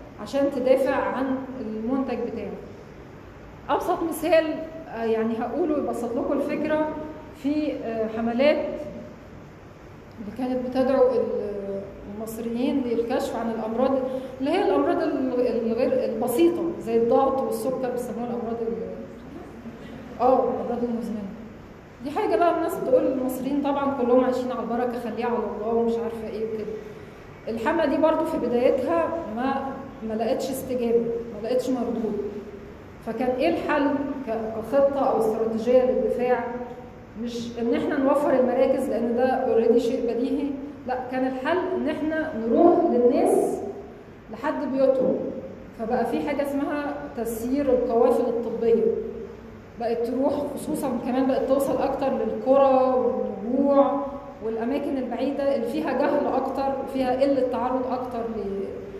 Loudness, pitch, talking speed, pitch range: -24 LUFS, 255 Hz, 120 wpm, 235-275 Hz